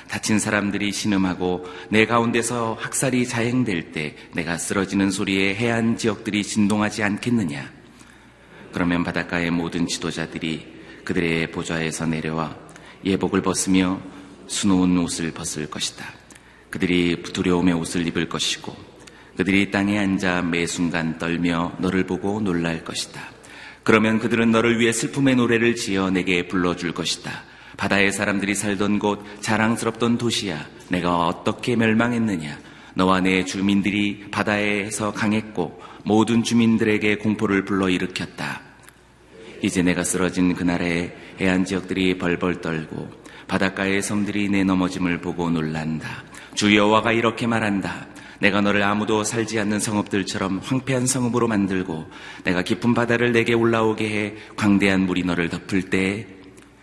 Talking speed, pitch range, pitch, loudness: 320 characters per minute, 90-110 Hz, 95 Hz, -22 LUFS